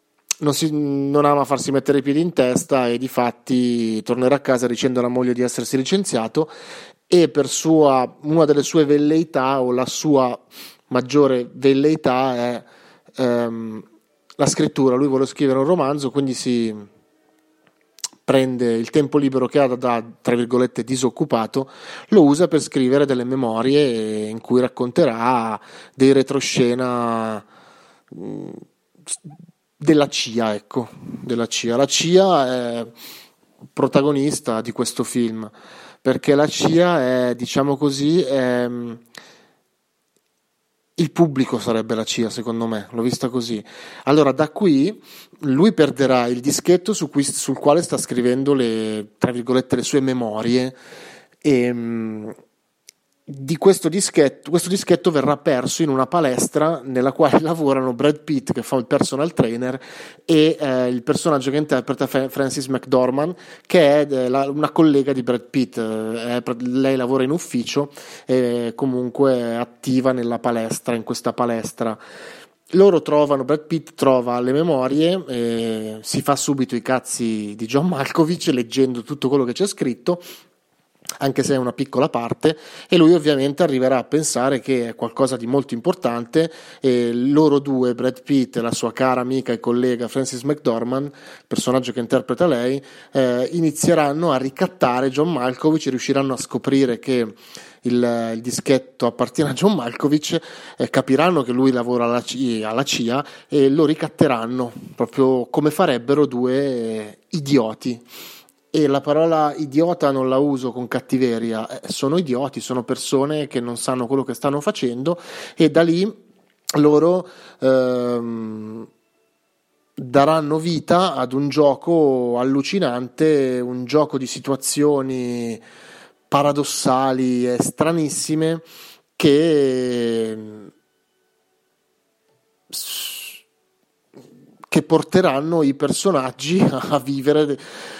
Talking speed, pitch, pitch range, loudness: 135 wpm, 135 Hz, 125-150 Hz, -19 LUFS